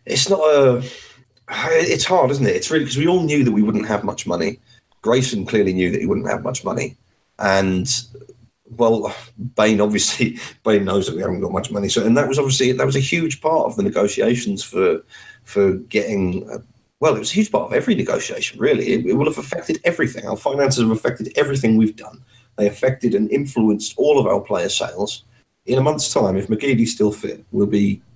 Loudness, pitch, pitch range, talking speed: -19 LUFS, 120 Hz, 105-145 Hz, 210 wpm